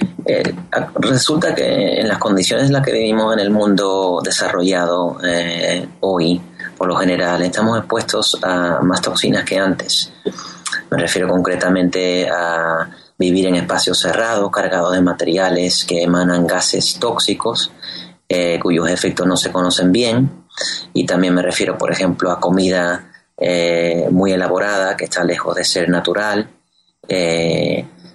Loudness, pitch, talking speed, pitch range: -16 LUFS, 90 Hz, 140 wpm, 85-95 Hz